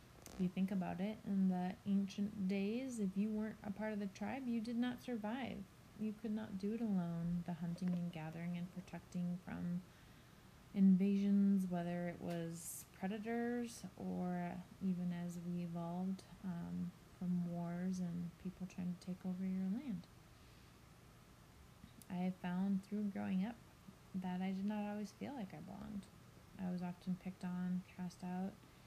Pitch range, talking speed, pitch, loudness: 180-205 Hz, 160 wpm, 185 Hz, -43 LUFS